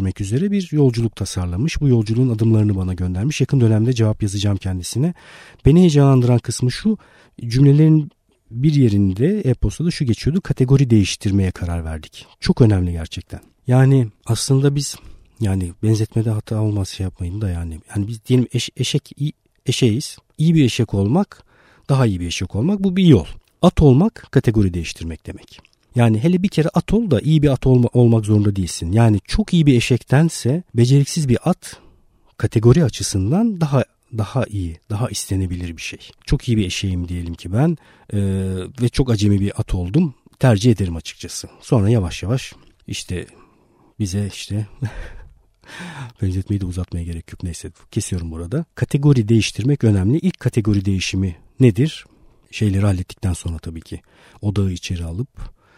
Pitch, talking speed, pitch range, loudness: 115 Hz, 155 wpm, 95-135 Hz, -18 LUFS